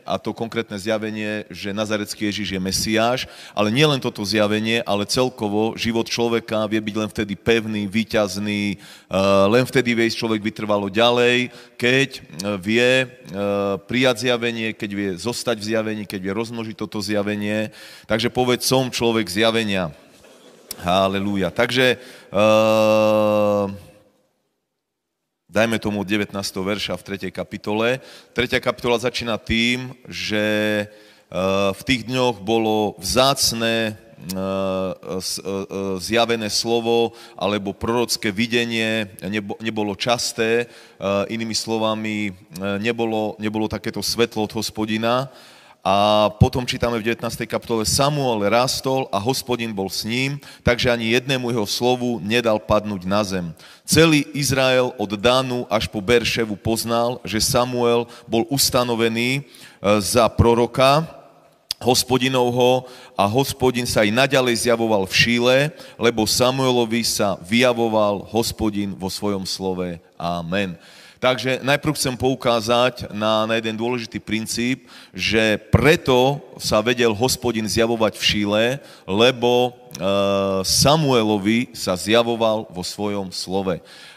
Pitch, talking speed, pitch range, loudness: 110 Hz, 115 wpm, 105-120 Hz, -20 LUFS